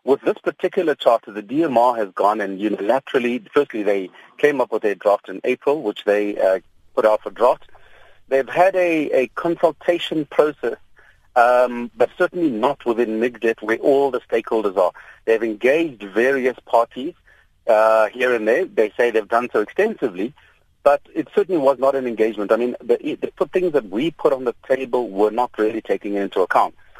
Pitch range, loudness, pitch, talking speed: 110-150 Hz, -20 LUFS, 125 Hz, 180 wpm